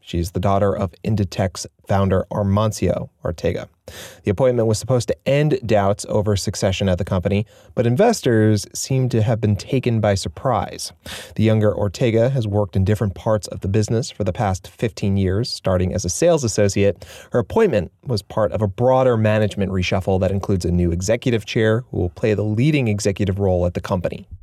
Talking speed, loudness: 185 wpm, -20 LUFS